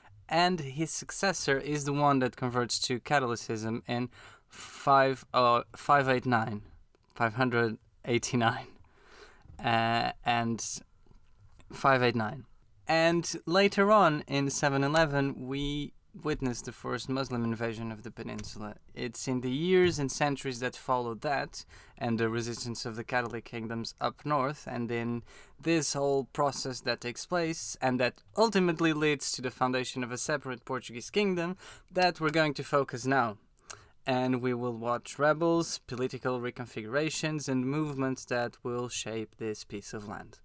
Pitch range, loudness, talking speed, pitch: 120-145 Hz, -30 LUFS, 135 wpm, 130 Hz